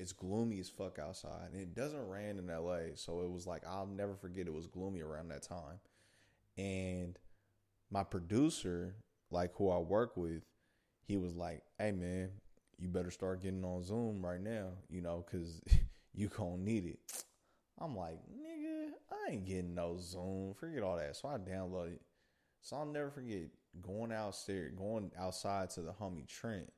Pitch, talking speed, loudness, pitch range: 95 Hz, 175 wpm, -43 LUFS, 90-100 Hz